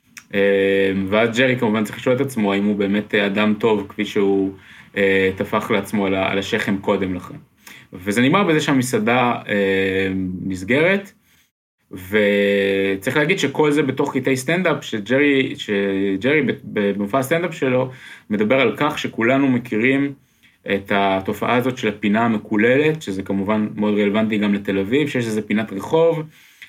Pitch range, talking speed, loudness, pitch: 100-135 Hz, 135 wpm, -19 LUFS, 105 Hz